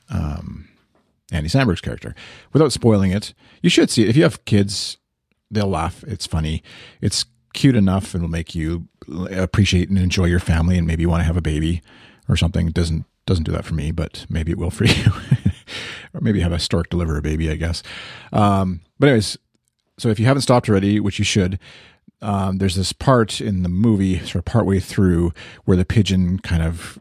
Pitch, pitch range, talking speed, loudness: 95 Hz, 85-110 Hz, 200 wpm, -19 LUFS